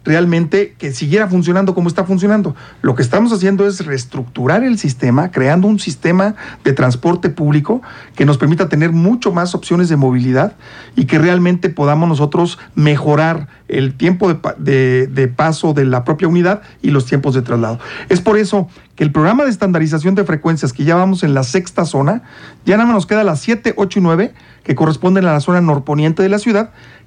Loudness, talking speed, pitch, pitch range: -14 LUFS, 195 wpm, 170 Hz, 145-195 Hz